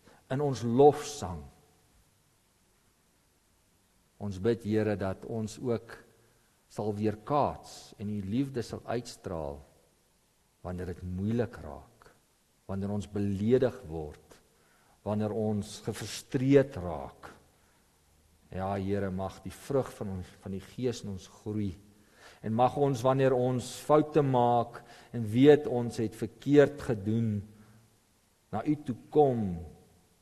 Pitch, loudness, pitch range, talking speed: 105 Hz, -30 LUFS, 95-120 Hz, 115 wpm